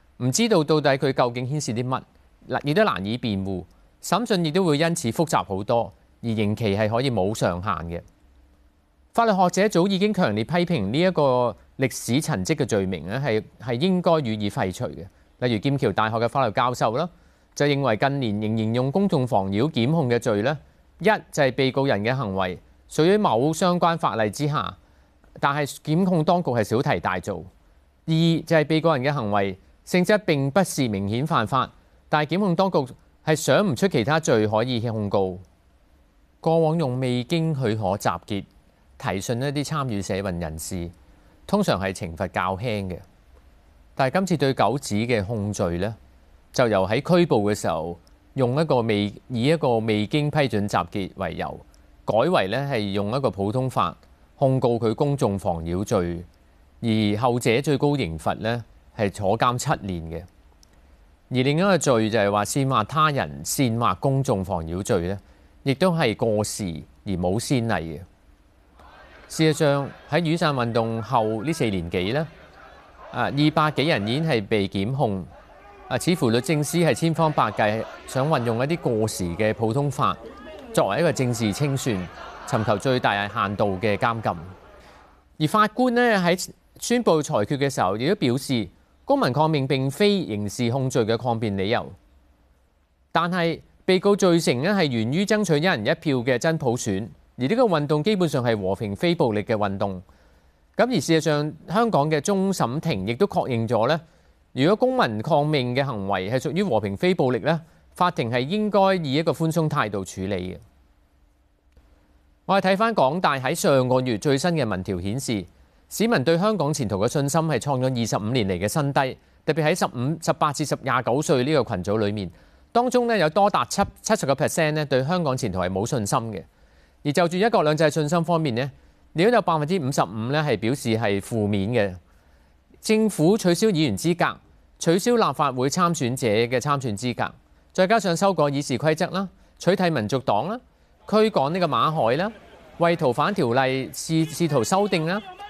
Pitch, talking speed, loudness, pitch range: 130 Hz, 260 characters per minute, -23 LUFS, 100-160 Hz